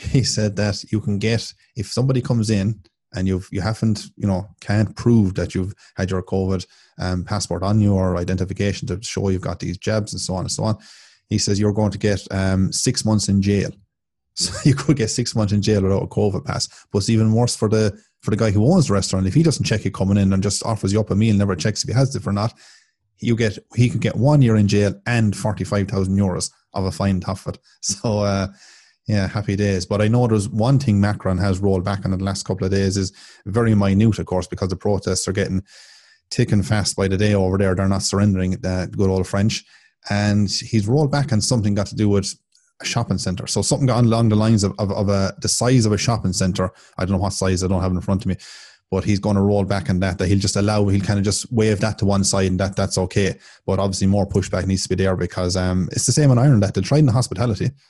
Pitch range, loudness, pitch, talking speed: 95-110 Hz, -20 LUFS, 100 Hz, 260 wpm